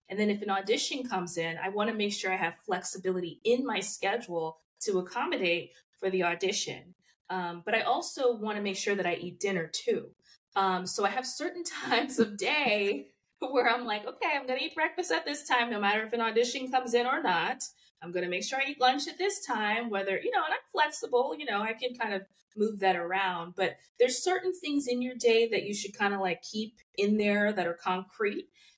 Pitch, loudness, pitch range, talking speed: 210 Hz, -30 LUFS, 190-255 Hz, 220 wpm